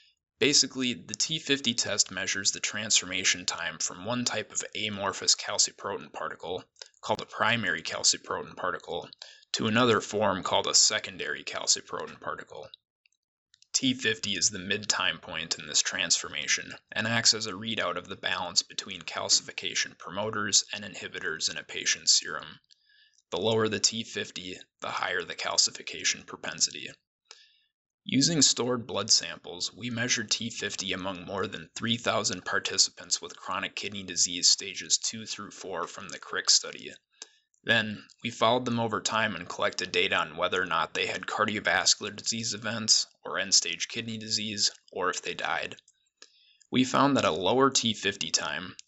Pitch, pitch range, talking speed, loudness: 115 Hz, 105-125 Hz, 145 wpm, -27 LUFS